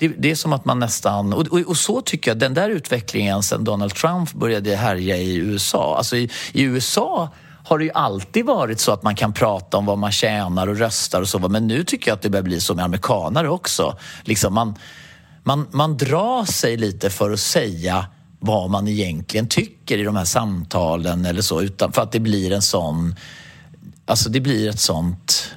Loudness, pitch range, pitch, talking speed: -20 LUFS, 100-135 Hz, 110 Hz, 210 wpm